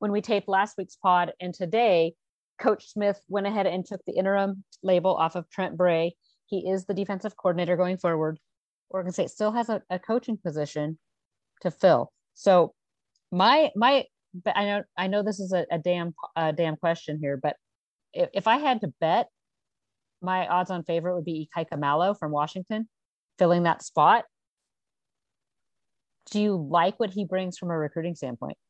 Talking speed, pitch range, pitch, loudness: 175 wpm, 170-200 Hz, 185 Hz, -26 LUFS